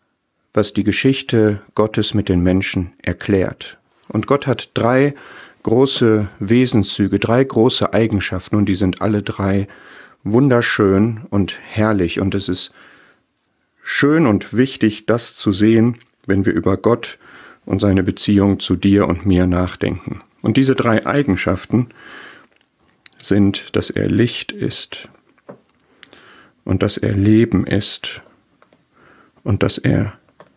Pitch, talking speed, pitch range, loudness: 105 Hz, 125 wpm, 95-115 Hz, -17 LUFS